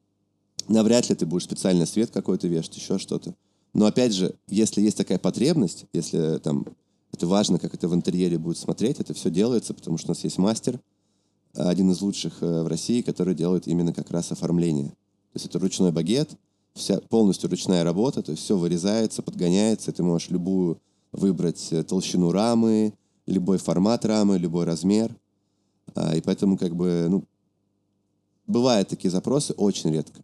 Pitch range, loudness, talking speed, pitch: 85-100 Hz, -24 LUFS, 165 wpm, 95 Hz